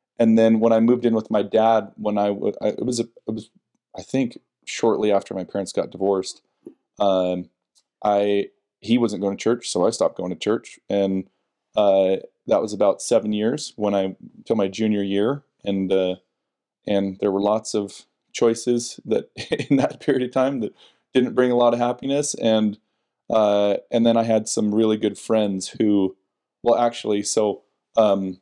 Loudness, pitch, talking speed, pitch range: -22 LUFS, 105 Hz, 180 wpm, 100-115 Hz